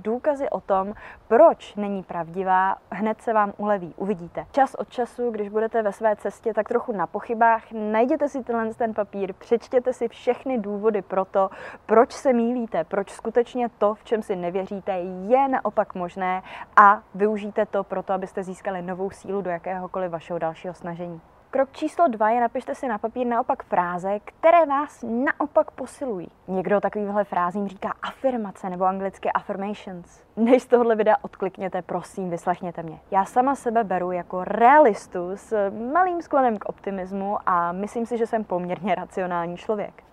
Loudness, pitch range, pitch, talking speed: -24 LUFS, 190-235 Hz, 210 Hz, 160 wpm